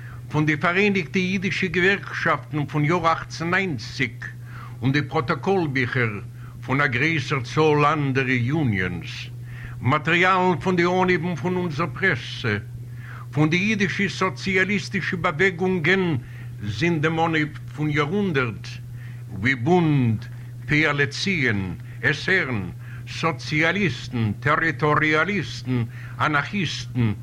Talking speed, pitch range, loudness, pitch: 90 wpm, 120-175 Hz, -22 LUFS, 145 Hz